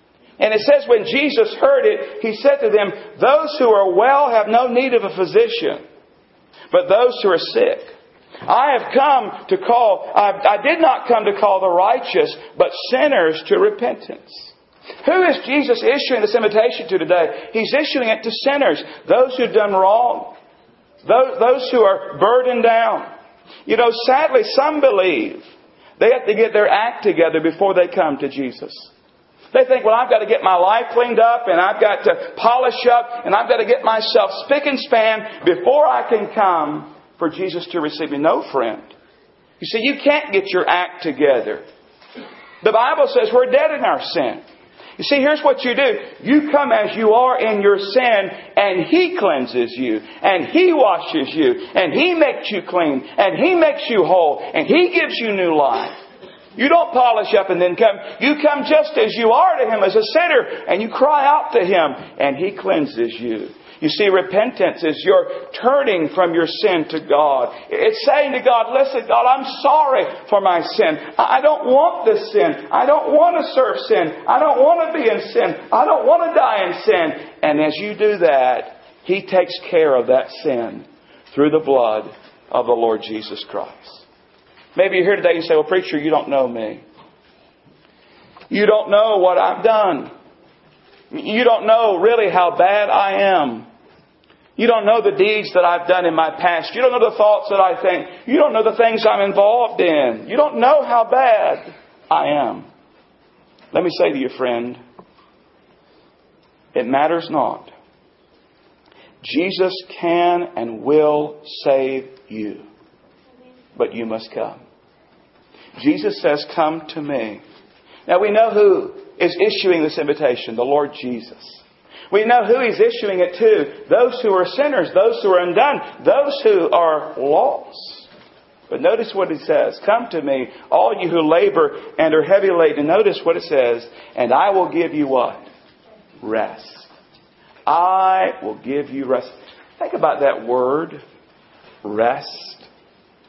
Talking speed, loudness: 175 wpm, -16 LUFS